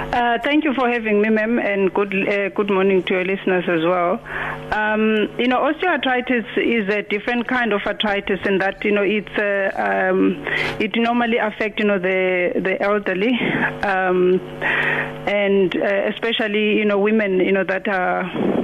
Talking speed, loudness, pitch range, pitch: 170 wpm, -19 LUFS, 190-225 Hz, 205 Hz